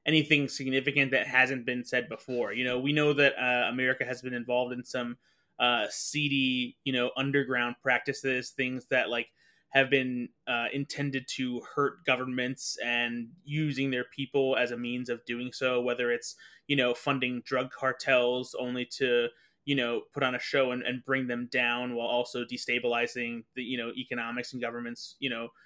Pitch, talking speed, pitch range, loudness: 125 Hz, 180 wpm, 120-135 Hz, -29 LUFS